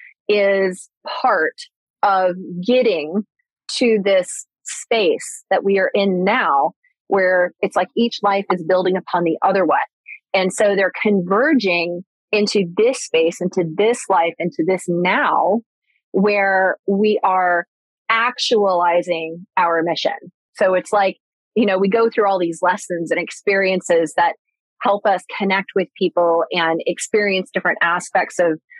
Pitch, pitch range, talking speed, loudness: 190 Hz, 180-210 Hz, 140 wpm, -18 LUFS